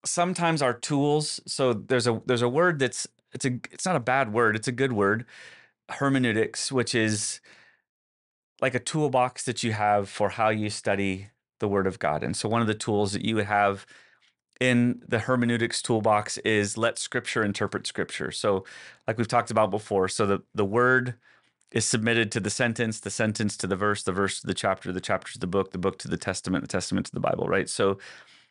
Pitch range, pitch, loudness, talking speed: 100-125 Hz, 110 Hz, -26 LUFS, 210 wpm